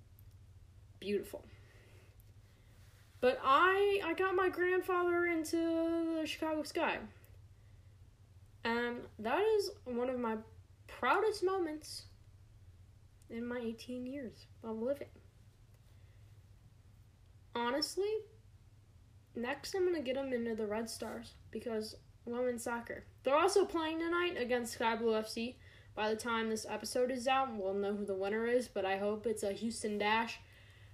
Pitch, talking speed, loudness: 220 Hz, 130 wpm, -36 LUFS